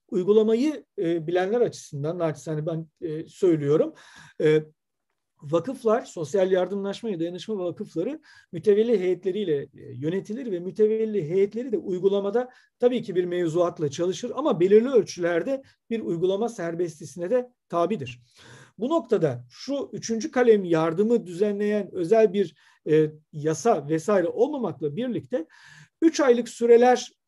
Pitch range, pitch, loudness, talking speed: 170-230 Hz, 195 Hz, -25 LUFS, 120 wpm